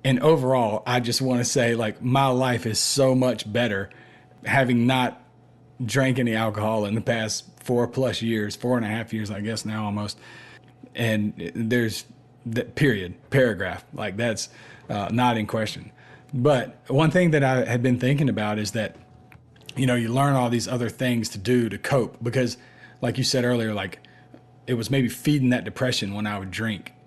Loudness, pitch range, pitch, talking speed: -24 LUFS, 110-130 Hz, 120 Hz, 185 wpm